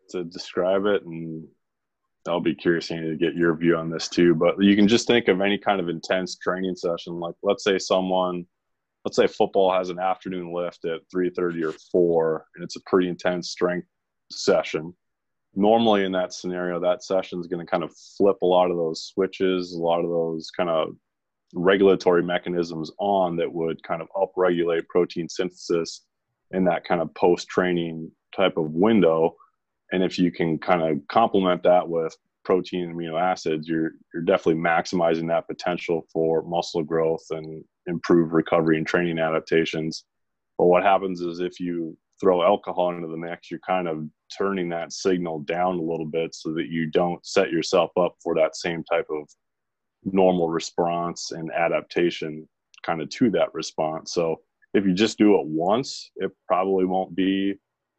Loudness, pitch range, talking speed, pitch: -24 LUFS, 80-90 Hz, 175 wpm, 85 Hz